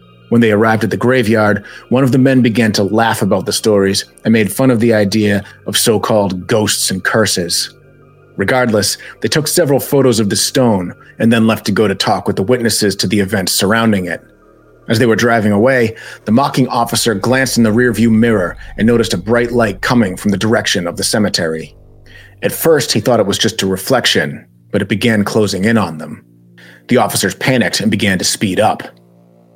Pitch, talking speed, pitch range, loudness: 110 Hz, 205 wpm, 100-120 Hz, -13 LUFS